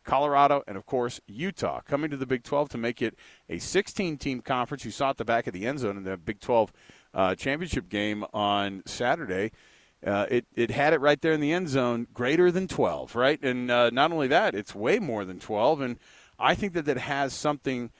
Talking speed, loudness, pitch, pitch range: 225 wpm, -27 LUFS, 130 Hz, 115-145 Hz